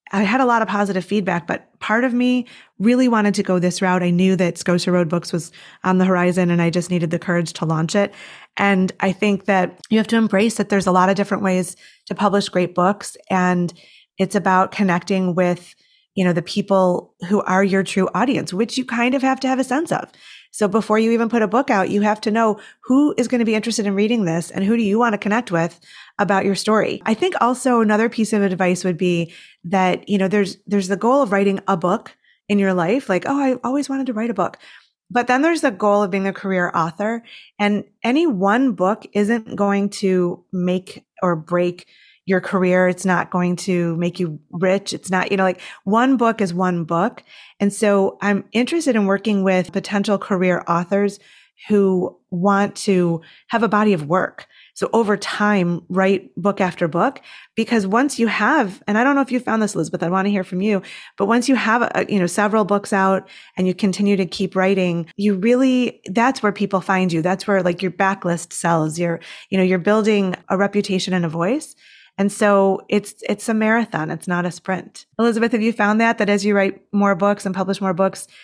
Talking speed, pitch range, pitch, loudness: 220 wpm, 185-220 Hz, 200 Hz, -19 LUFS